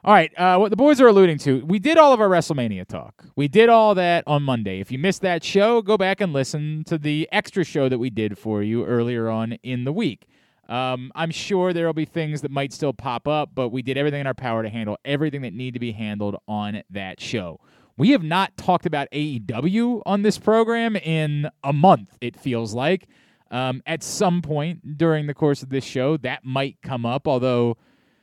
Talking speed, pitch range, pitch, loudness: 225 wpm, 125-180 Hz, 145 Hz, -21 LUFS